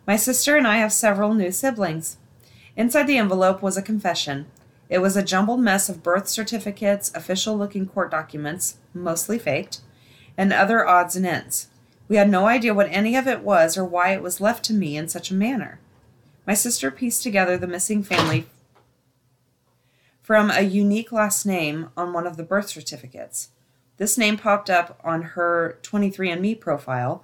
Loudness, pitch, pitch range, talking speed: -21 LUFS, 185 Hz, 155-210 Hz, 175 wpm